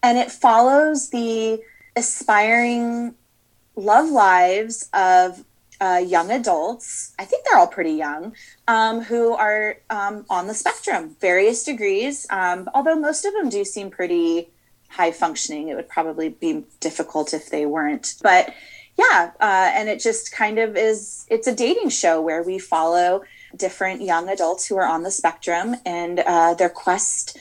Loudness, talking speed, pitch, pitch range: -20 LUFS, 160 wpm, 210 Hz, 175-235 Hz